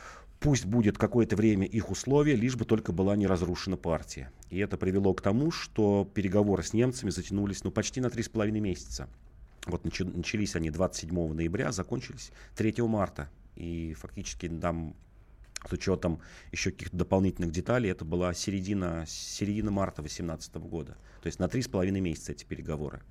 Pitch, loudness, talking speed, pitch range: 95 Hz, -31 LUFS, 155 wpm, 85-105 Hz